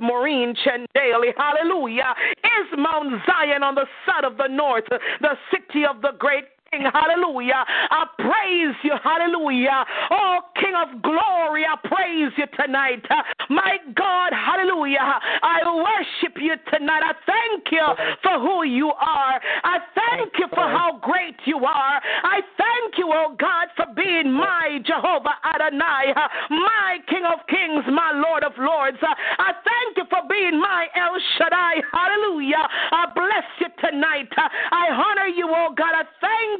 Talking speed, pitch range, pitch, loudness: 150 wpm, 285-355 Hz, 320 Hz, -20 LUFS